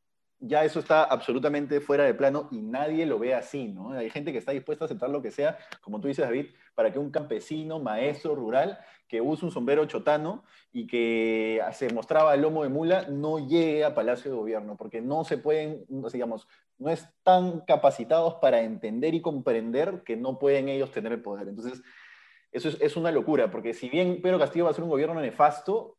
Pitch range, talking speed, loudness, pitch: 135-170 Hz, 210 wpm, -27 LUFS, 155 Hz